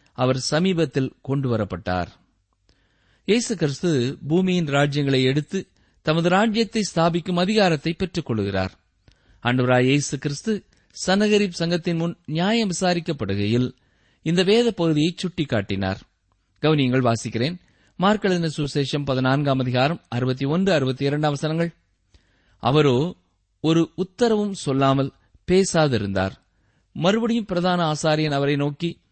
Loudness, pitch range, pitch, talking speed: -22 LUFS, 120-175 Hz, 145 Hz, 75 wpm